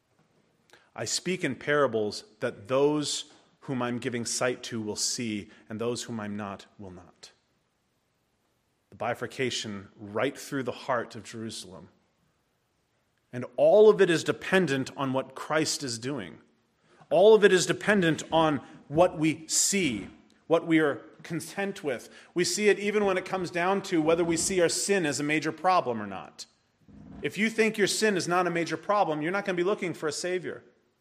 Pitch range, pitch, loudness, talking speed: 120-180 Hz, 155 Hz, -27 LUFS, 180 wpm